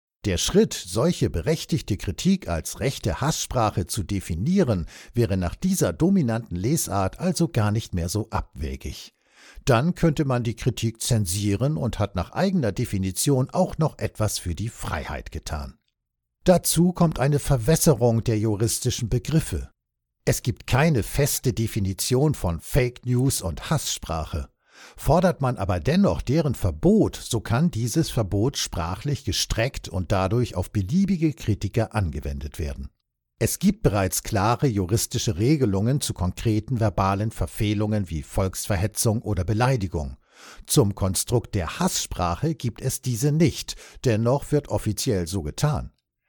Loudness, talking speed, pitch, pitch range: -24 LUFS, 130 wpm, 110 Hz, 95-135 Hz